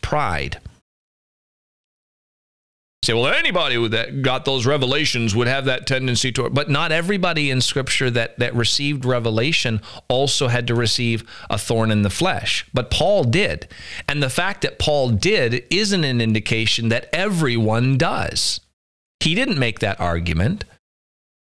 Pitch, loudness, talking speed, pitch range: 125 Hz, -19 LUFS, 150 wpm, 115-140 Hz